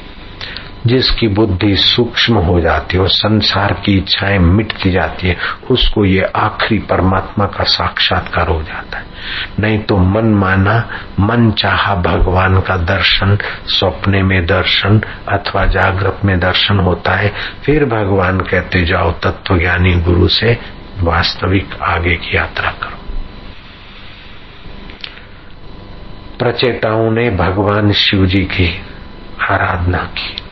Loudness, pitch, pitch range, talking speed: -13 LUFS, 95 Hz, 90-100 Hz, 120 wpm